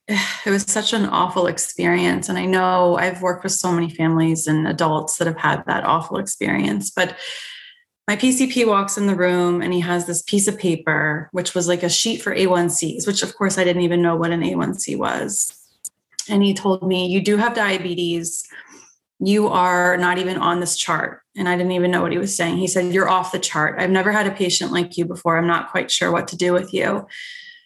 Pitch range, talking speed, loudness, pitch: 175-195 Hz, 220 wpm, -19 LUFS, 180 Hz